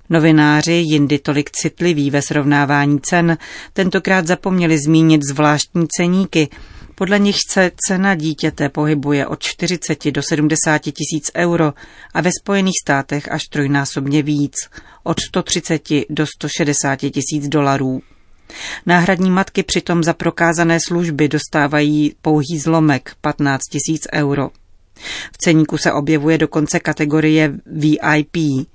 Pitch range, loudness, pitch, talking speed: 145-170 Hz, -16 LUFS, 155 Hz, 115 wpm